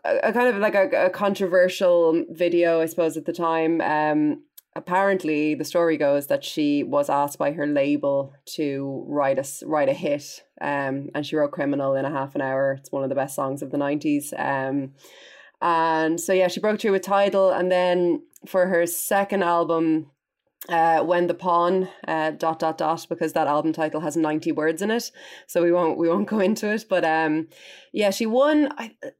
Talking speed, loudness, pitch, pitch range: 200 wpm, -23 LUFS, 165 Hz, 150-195 Hz